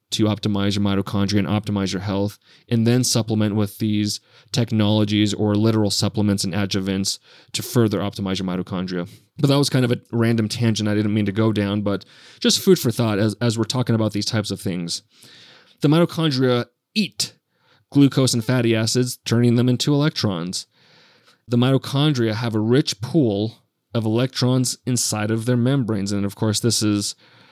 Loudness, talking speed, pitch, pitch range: -21 LUFS, 175 wpm, 110 Hz, 105-125 Hz